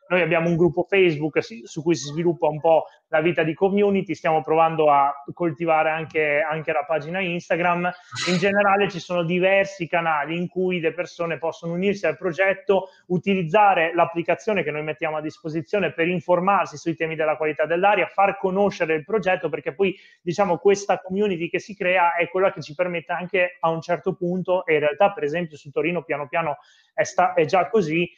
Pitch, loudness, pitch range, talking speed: 175 Hz, -22 LUFS, 160-185 Hz, 185 wpm